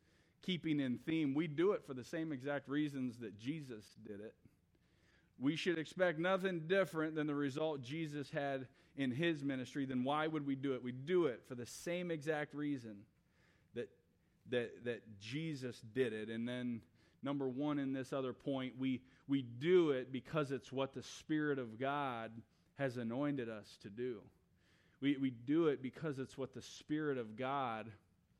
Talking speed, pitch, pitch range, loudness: 175 wpm, 135 Hz, 125-150 Hz, -41 LUFS